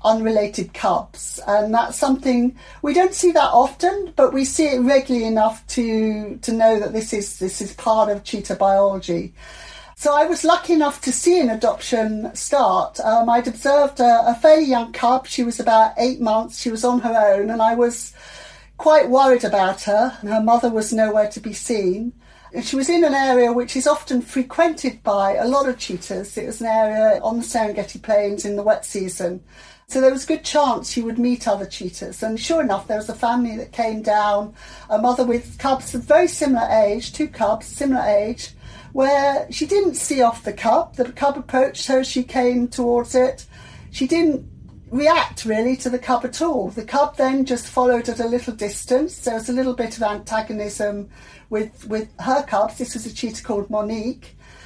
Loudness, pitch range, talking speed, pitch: -19 LUFS, 220-265 Hz, 200 wpm, 240 Hz